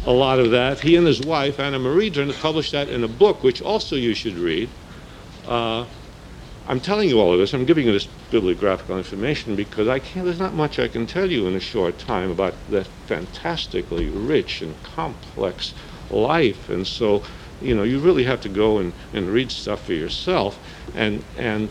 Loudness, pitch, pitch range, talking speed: -21 LUFS, 130 Hz, 105-155 Hz, 200 wpm